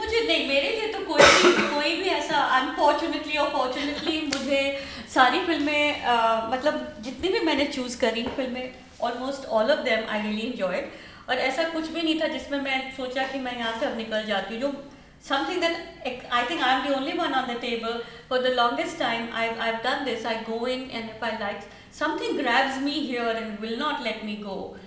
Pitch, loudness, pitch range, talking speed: 265 Hz, -25 LUFS, 235-300 Hz, 200 wpm